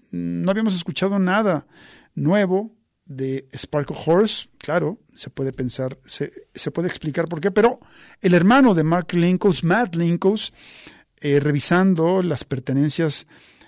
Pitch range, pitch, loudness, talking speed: 145-195 Hz, 170 Hz, -20 LUFS, 130 wpm